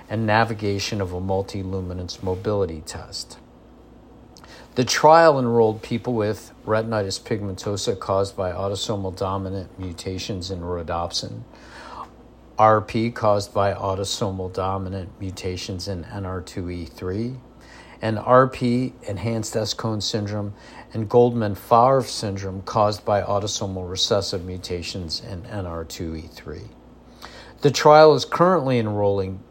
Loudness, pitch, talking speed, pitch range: -22 LUFS, 100 Hz, 100 wpm, 95-115 Hz